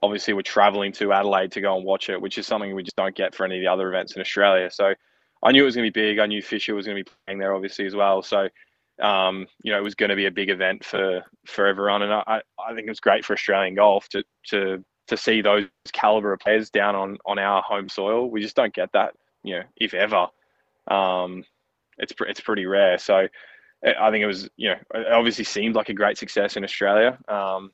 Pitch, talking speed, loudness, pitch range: 100 Hz, 250 wpm, -22 LUFS, 95-105 Hz